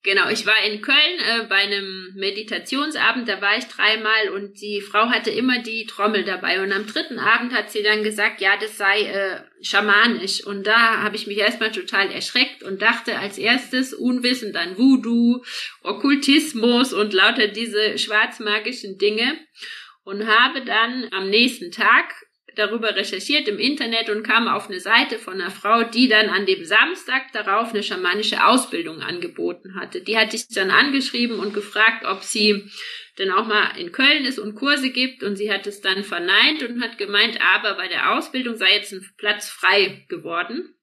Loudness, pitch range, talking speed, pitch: -19 LUFS, 205-250 Hz, 180 wpm, 215 Hz